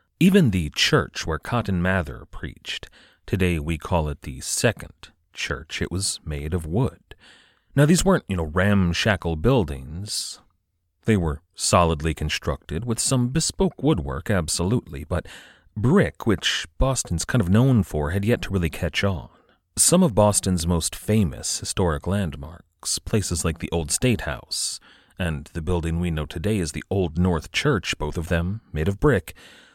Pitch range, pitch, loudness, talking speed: 85-105 Hz, 90 Hz, -23 LUFS, 160 wpm